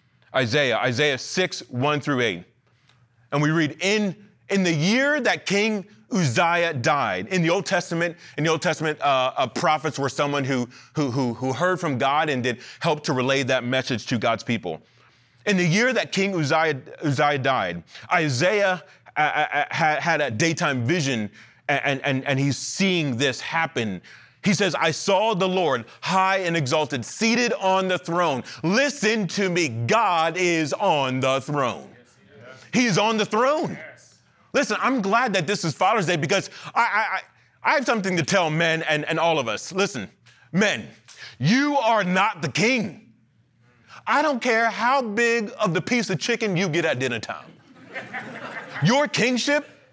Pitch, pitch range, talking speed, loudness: 170 Hz, 140-200 Hz, 170 wpm, -22 LUFS